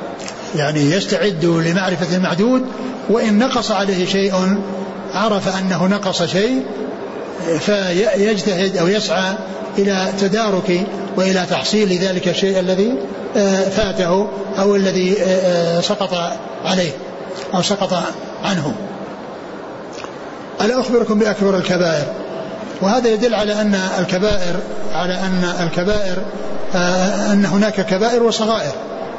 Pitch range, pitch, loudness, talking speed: 180-210 Hz, 190 Hz, -17 LUFS, 95 wpm